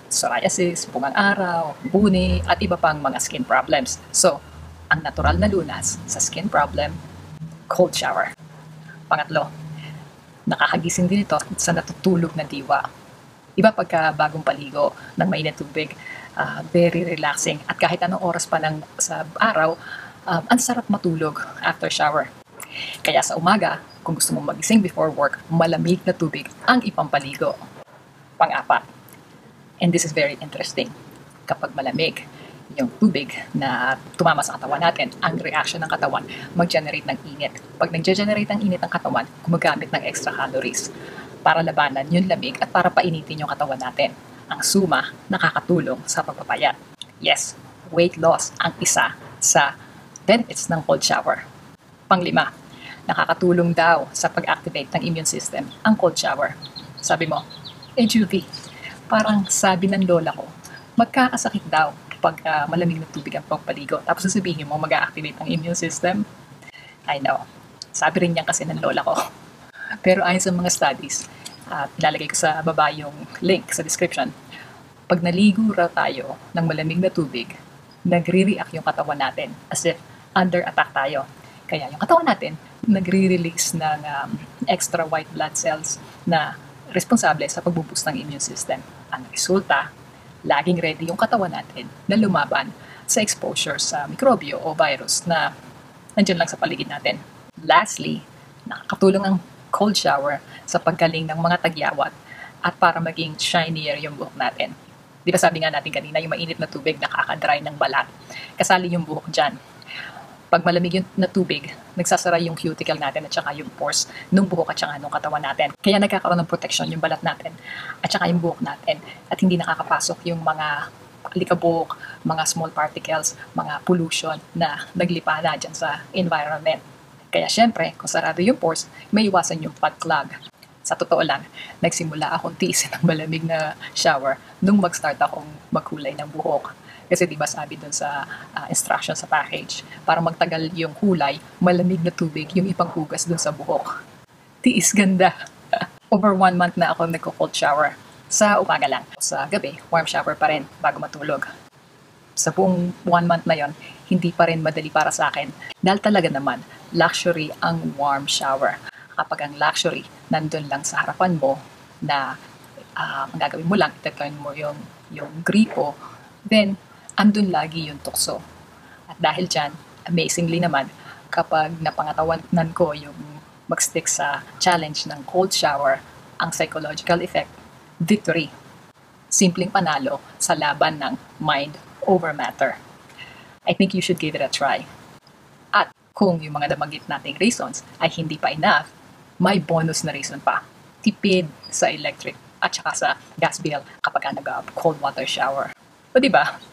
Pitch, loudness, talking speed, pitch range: 170 Hz, -21 LUFS, 150 wpm, 155-185 Hz